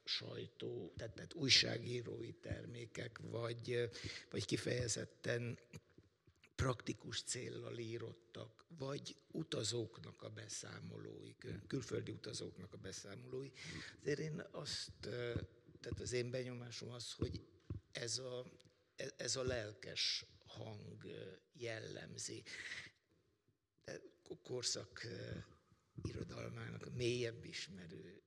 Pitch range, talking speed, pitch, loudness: 115-130 Hz, 90 wpm, 120 Hz, -45 LUFS